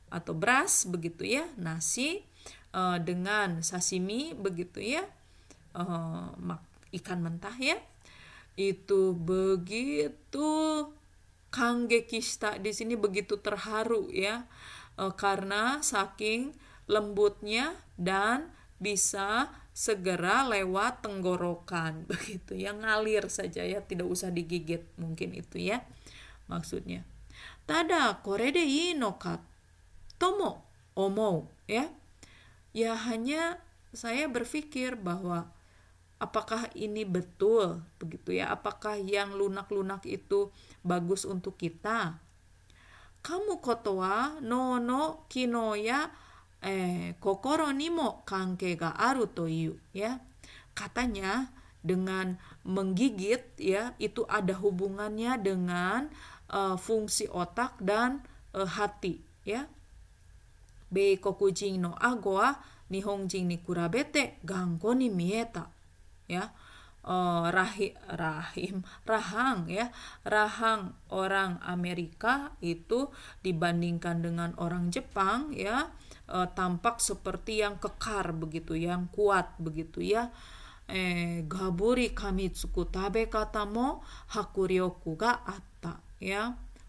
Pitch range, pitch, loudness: 180-230 Hz, 195 Hz, -32 LUFS